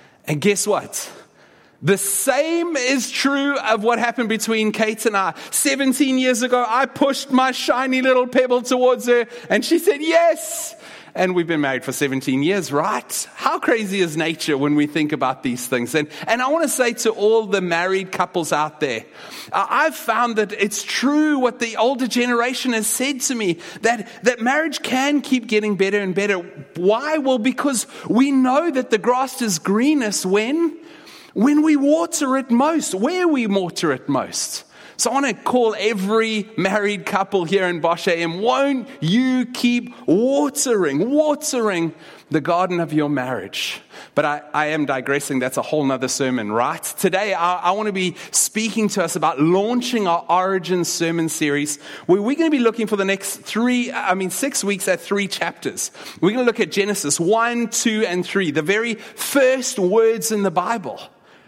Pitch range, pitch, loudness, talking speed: 180-260 Hz, 220 Hz, -19 LUFS, 180 wpm